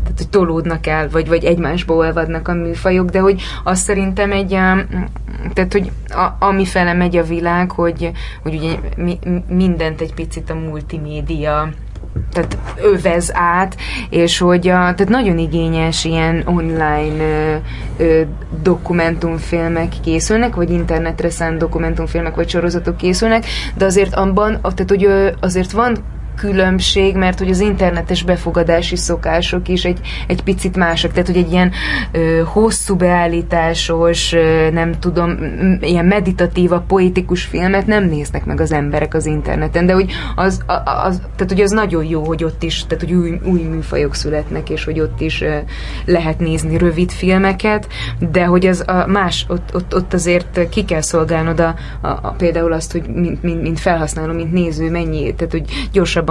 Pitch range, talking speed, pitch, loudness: 165-185 Hz, 160 wpm, 170 Hz, -15 LUFS